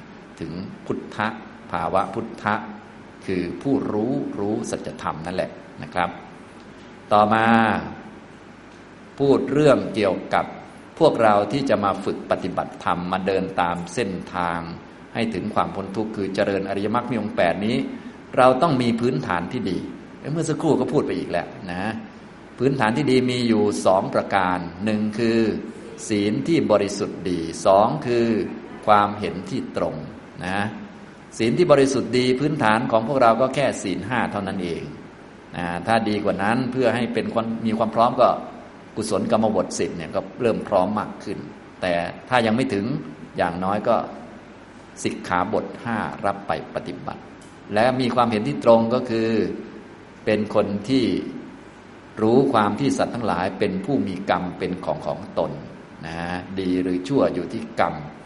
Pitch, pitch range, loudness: 110 Hz, 95-120 Hz, -22 LUFS